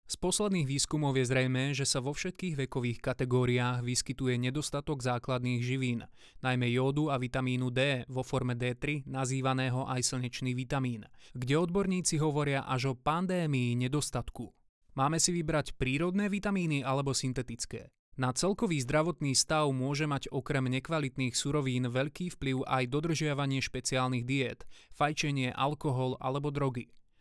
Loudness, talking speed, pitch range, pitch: -32 LUFS, 130 wpm, 130-150 Hz, 135 Hz